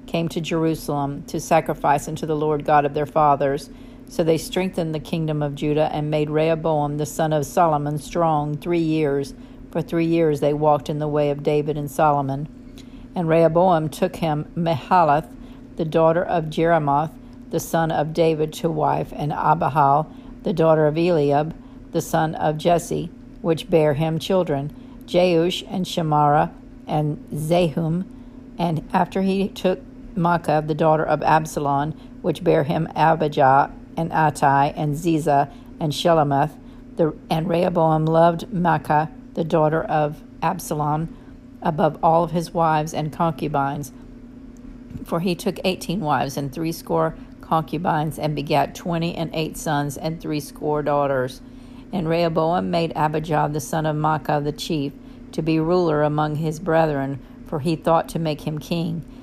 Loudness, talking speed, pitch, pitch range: -21 LUFS, 150 wpm, 160 Hz, 150-170 Hz